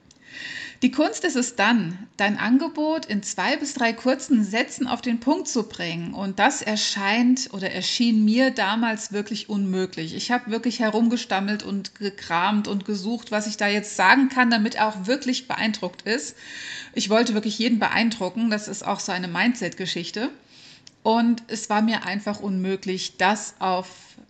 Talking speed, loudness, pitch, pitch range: 165 wpm, -23 LUFS, 215 Hz, 195-240 Hz